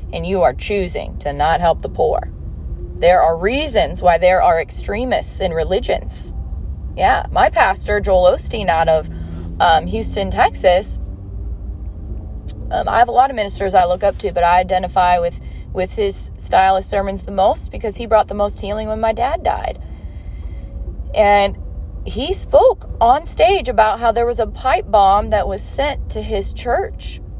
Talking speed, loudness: 170 wpm, -16 LUFS